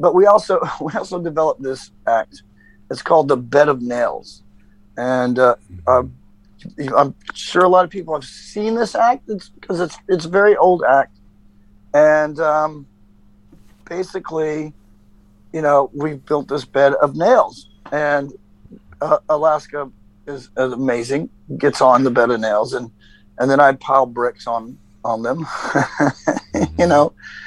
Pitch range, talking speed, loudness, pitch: 105-155 Hz, 150 wpm, -17 LUFS, 135 Hz